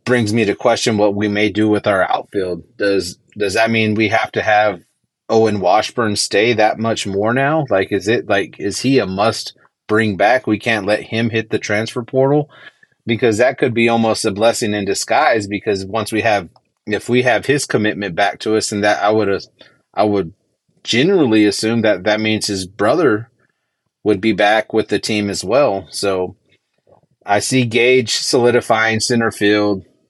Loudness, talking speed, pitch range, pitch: -16 LUFS, 185 wpm, 105-115 Hz, 110 Hz